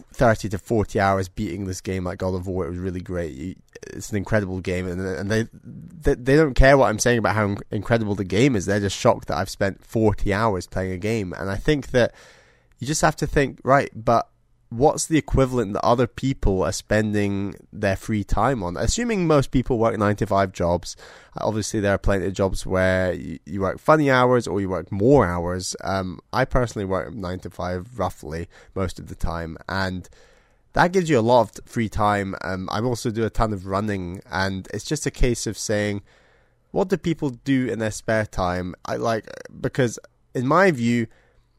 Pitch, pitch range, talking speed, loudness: 105 Hz, 95-120 Hz, 205 wpm, -23 LUFS